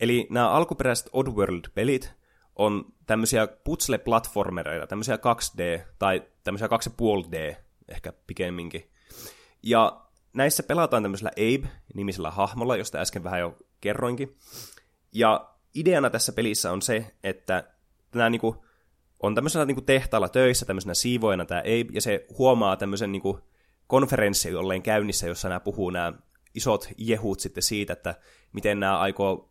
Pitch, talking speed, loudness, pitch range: 105 Hz, 120 wpm, -26 LUFS, 95-120 Hz